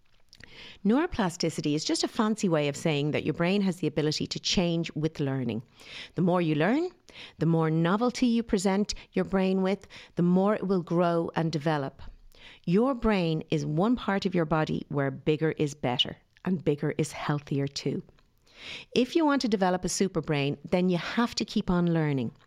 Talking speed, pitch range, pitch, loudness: 185 wpm, 155-200 Hz, 170 Hz, -28 LUFS